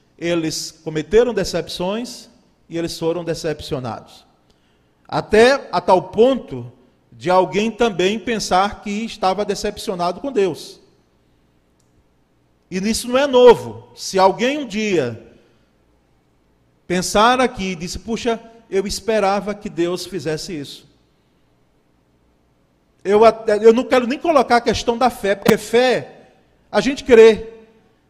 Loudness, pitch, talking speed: -17 LUFS, 190 Hz, 115 wpm